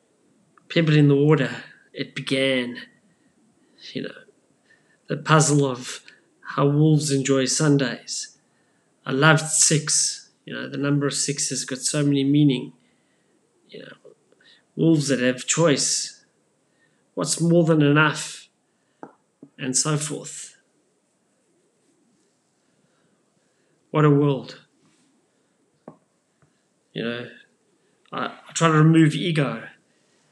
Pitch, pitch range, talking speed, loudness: 145 Hz, 135-155 Hz, 105 wpm, -21 LUFS